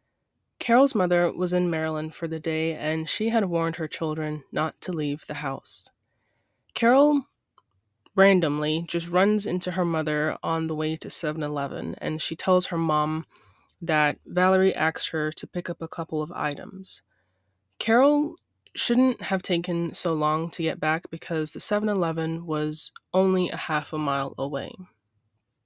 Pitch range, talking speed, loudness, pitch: 150-185 Hz, 160 wpm, -25 LUFS, 160 Hz